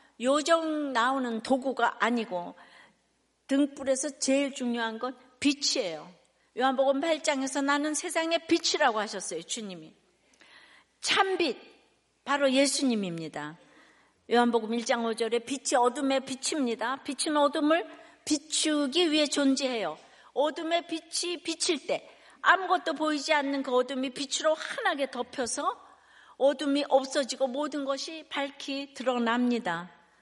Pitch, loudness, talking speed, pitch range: 275 Hz, -28 LUFS, 270 characters per minute, 250-310 Hz